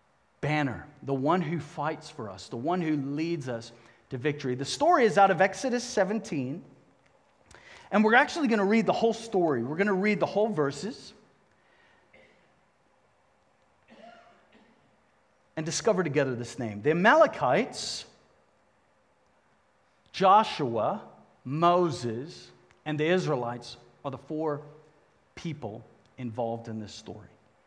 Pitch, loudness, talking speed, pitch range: 150 Hz, -27 LUFS, 125 wpm, 120-190 Hz